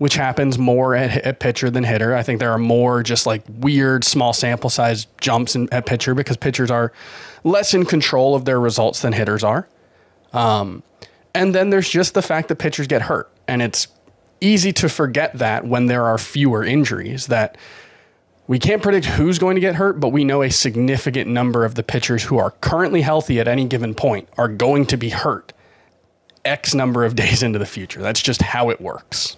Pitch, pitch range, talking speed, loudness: 125 Hz, 115-145 Hz, 205 wpm, -18 LUFS